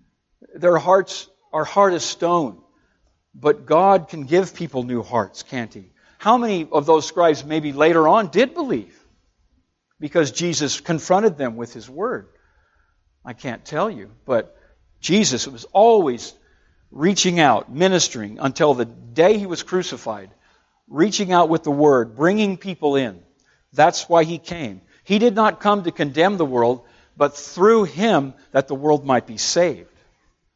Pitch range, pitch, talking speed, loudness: 130-185 Hz, 160 Hz, 155 wpm, -19 LUFS